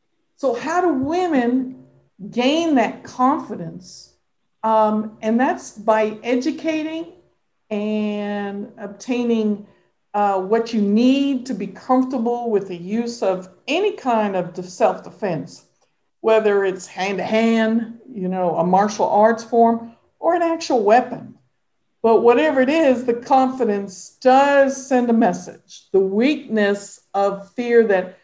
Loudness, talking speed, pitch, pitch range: -19 LUFS, 120 wpm, 225 Hz, 205-260 Hz